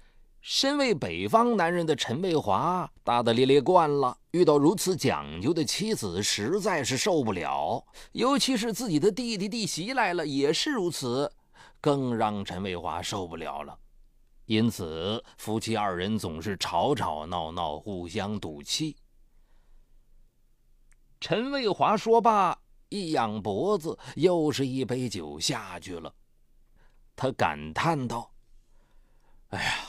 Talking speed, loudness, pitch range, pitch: 195 characters per minute, -27 LUFS, 110-180 Hz, 130 Hz